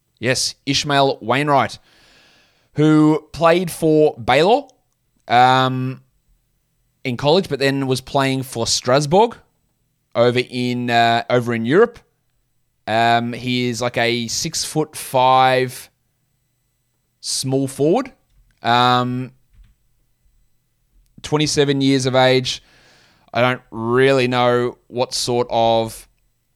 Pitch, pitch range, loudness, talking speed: 125 Hz, 120-135 Hz, -17 LUFS, 100 wpm